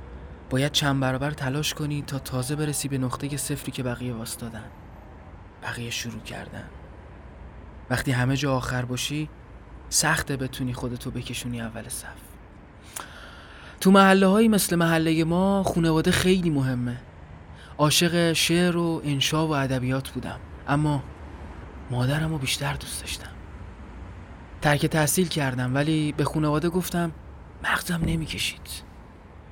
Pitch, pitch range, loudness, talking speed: 130 Hz, 95-150 Hz, -24 LUFS, 120 wpm